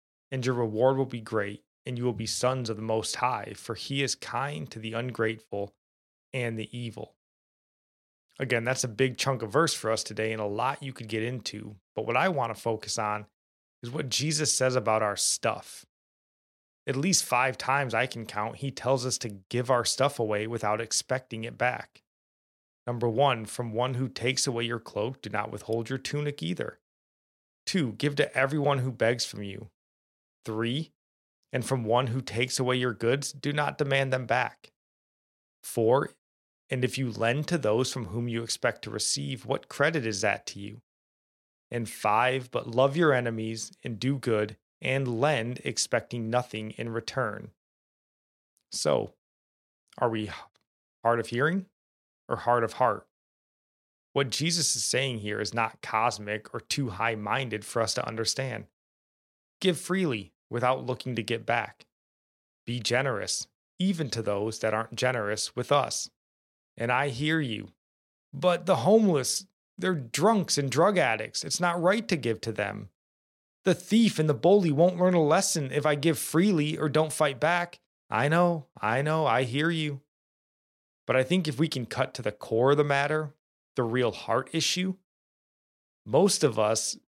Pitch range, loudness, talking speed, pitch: 110-145 Hz, -28 LUFS, 175 wpm, 125 Hz